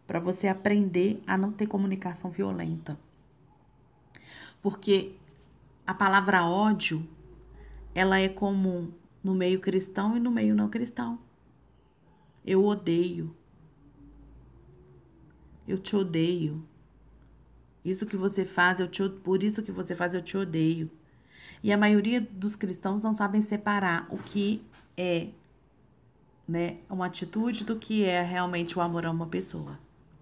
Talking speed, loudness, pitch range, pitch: 130 wpm, -28 LUFS, 165-200 Hz, 185 Hz